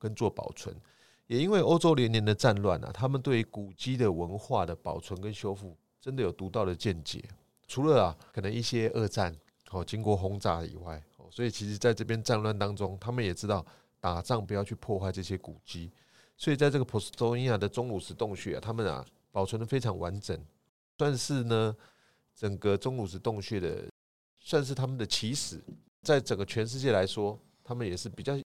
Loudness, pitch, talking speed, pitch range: -31 LUFS, 105 Hz, 305 characters per minute, 95-120 Hz